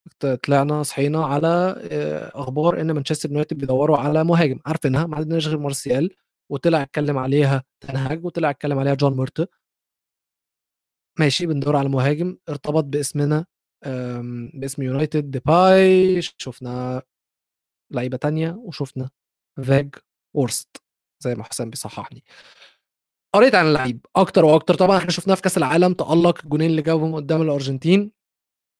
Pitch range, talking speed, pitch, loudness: 135-165 Hz, 125 wpm, 150 Hz, -20 LUFS